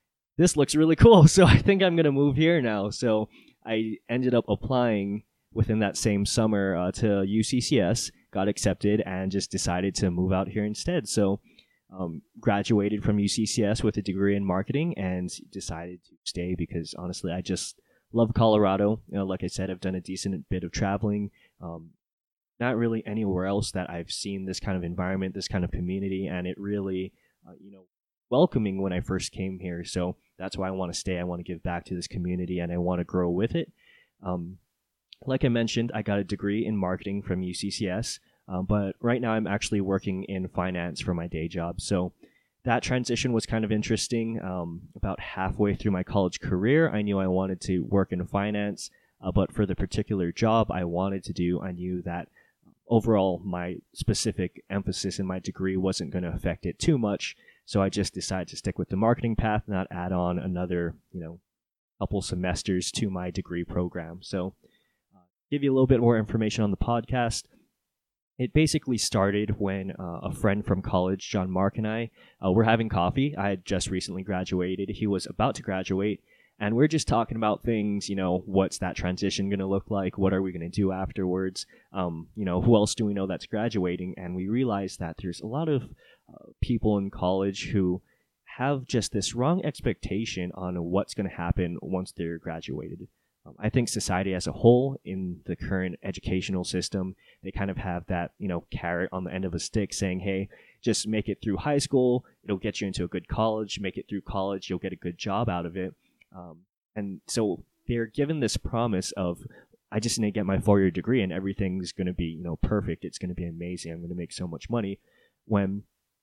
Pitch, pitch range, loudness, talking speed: 95 Hz, 90-110 Hz, -27 LUFS, 205 wpm